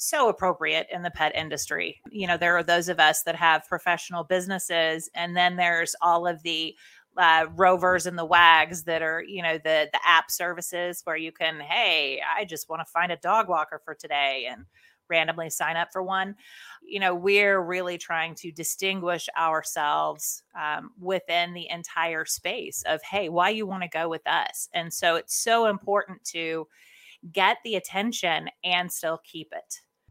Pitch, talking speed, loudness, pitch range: 170 Hz, 180 wpm, -25 LUFS, 160-185 Hz